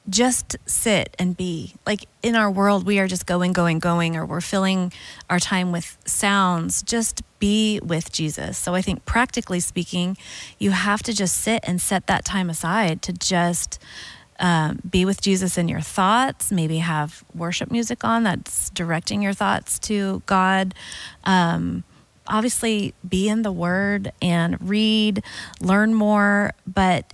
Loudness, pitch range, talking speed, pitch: -21 LUFS, 175-205 Hz, 155 wpm, 190 Hz